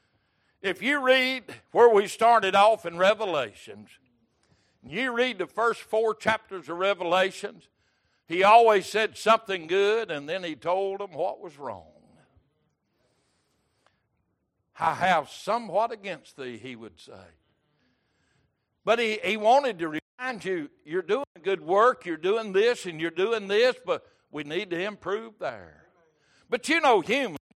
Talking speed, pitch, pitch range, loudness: 145 wpm, 220 Hz, 185-260 Hz, -25 LUFS